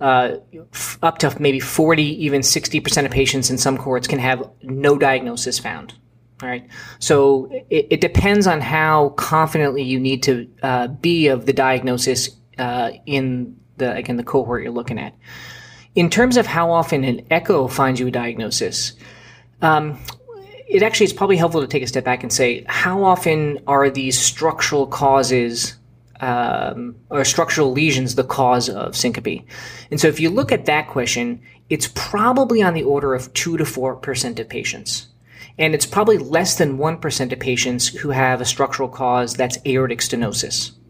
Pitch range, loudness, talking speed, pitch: 125-155 Hz, -18 LUFS, 175 wpm, 135 Hz